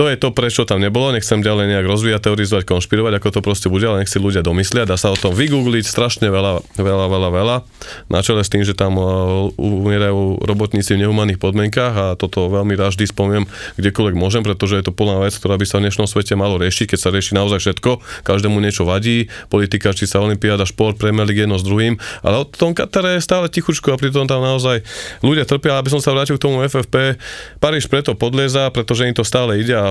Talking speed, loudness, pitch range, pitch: 220 wpm, -16 LUFS, 100-120 Hz, 105 Hz